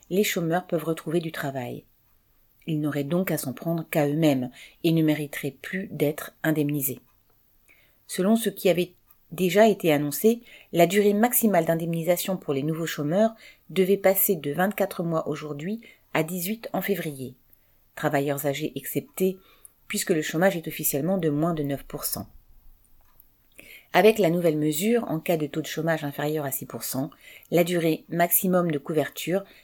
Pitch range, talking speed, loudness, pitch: 145-185 Hz, 150 wpm, -25 LUFS, 165 Hz